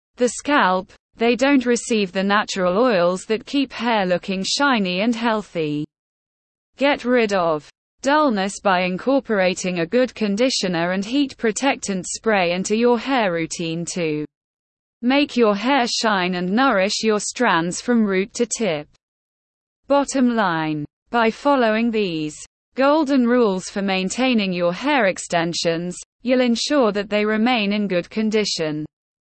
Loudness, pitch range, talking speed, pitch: -20 LUFS, 180-245 Hz, 135 wpm, 215 Hz